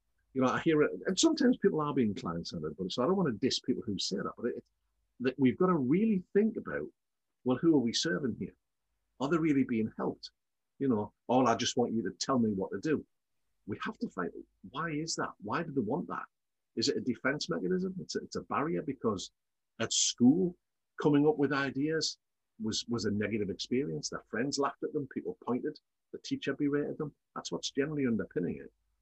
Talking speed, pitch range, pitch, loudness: 220 wpm, 120-165 Hz, 140 Hz, -32 LUFS